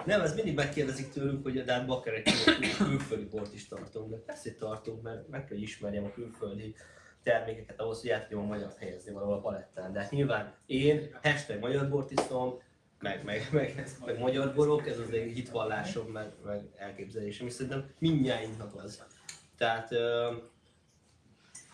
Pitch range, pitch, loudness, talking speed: 105-135 Hz, 115 Hz, -33 LUFS, 160 wpm